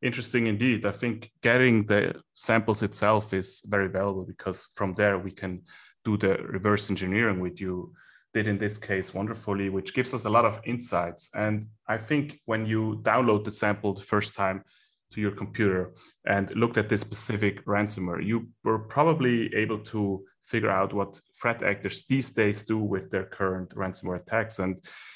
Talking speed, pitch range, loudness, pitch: 175 wpm, 95-110 Hz, -27 LUFS, 105 Hz